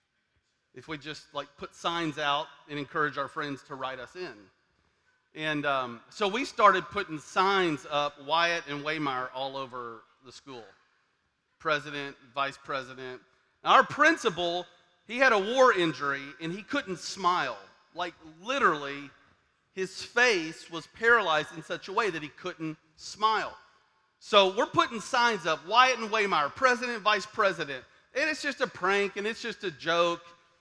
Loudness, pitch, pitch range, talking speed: -28 LUFS, 170 Hz, 145-210 Hz, 155 wpm